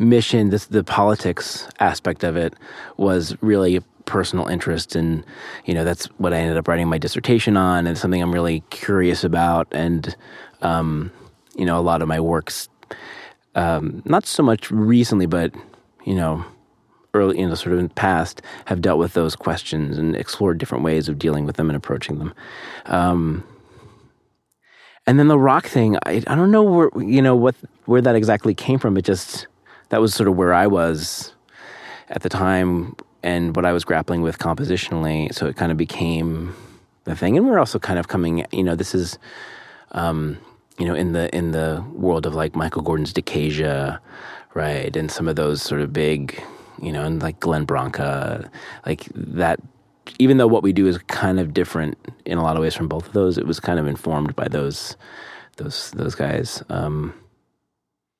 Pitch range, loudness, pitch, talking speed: 80-100 Hz, -20 LUFS, 85 Hz, 190 wpm